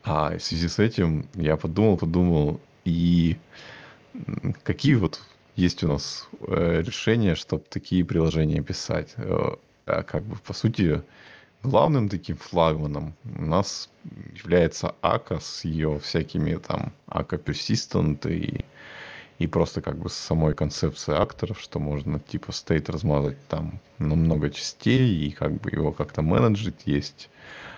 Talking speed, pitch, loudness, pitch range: 125 wpm, 80 Hz, -25 LUFS, 75-90 Hz